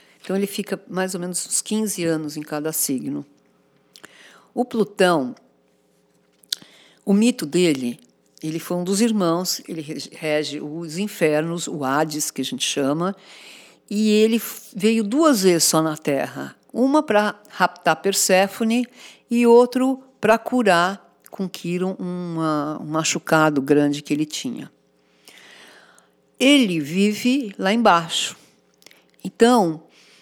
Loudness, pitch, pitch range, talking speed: -20 LUFS, 180 Hz, 155-215 Hz, 120 wpm